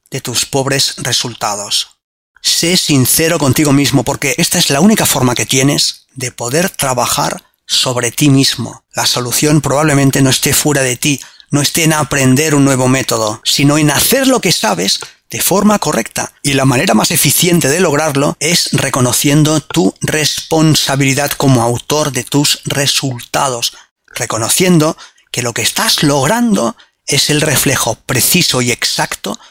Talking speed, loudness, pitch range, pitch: 150 wpm, -11 LUFS, 130-155 Hz, 145 Hz